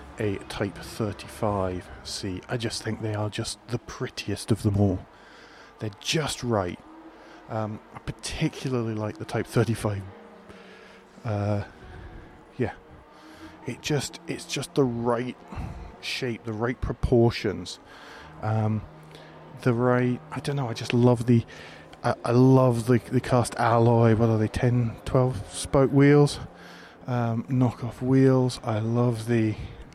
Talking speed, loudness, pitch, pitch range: 135 wpm, -26 LUFS, 115 Hz, 105-125 Hz